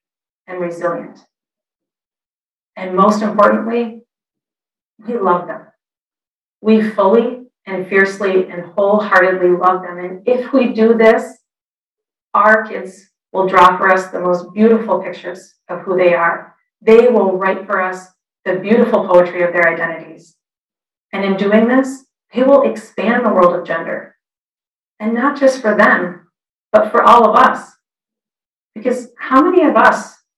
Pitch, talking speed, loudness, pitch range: 195 Hz, 140 wpm, -13 LUFS, 180-230 Hz